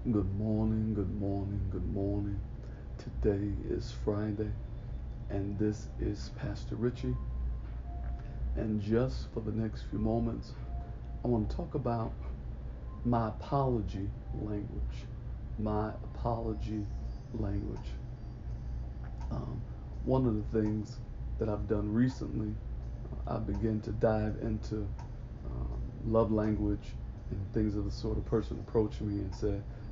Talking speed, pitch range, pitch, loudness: 120 wpm, 100-110 Hz, 105 Hz, -35 LUFS